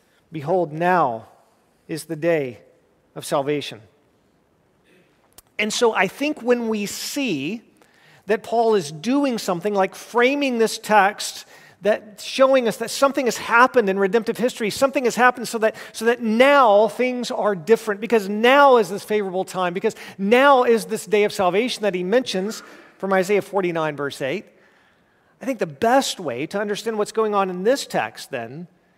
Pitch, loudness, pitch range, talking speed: 215 Hz, -20 LUFS, 190-240 Hz, 165 wpm